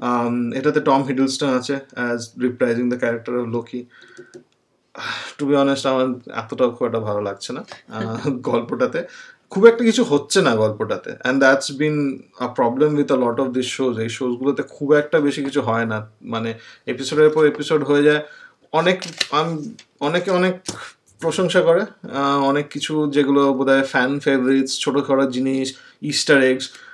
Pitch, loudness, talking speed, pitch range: 140 Hz, -19 LUFS, 135 wpm, 125-150 Hz